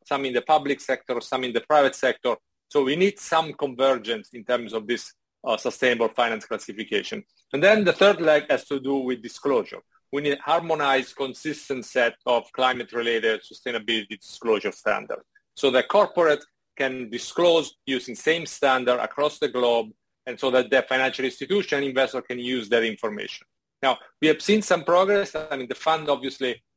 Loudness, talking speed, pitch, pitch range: -24 LUFS, 175 wpm, 135 Hz, 125-155 Hz